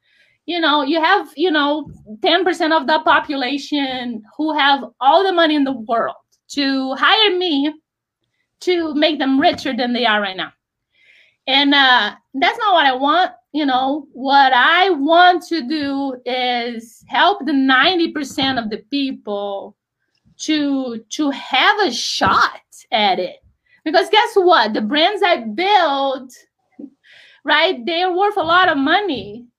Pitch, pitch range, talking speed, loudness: 290 Hz, 265-340 Hz, 145 wpm, -16 LUFS